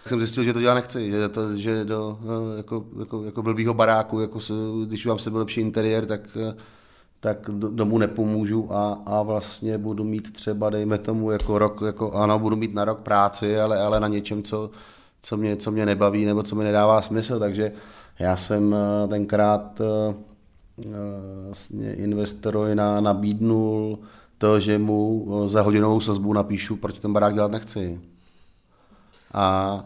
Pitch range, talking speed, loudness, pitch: 105-110 Hz, 160 wpm, -24 LUFS, 105 Hz